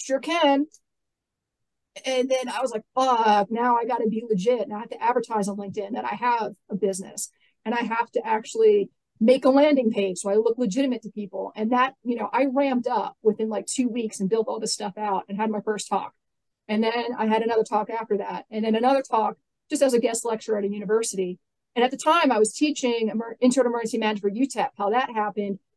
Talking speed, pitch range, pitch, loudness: 230 wpm, 210-255 Hz, 225 Hz, -24 LUFS